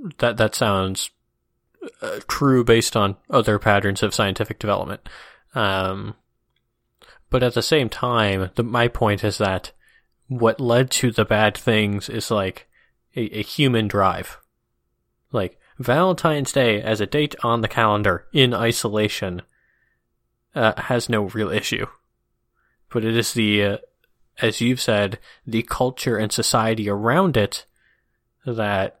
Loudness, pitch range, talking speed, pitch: -21 LUFS, 105-120 Hz, 135 wpm, 115 Hz